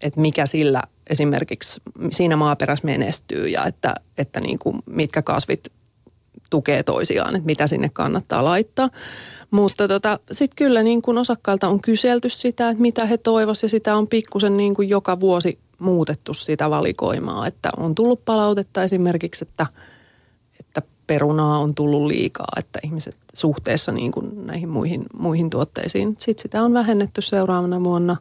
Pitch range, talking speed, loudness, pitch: 155-220 Hz, 150 wpm, -20 LUFS, 190 Hz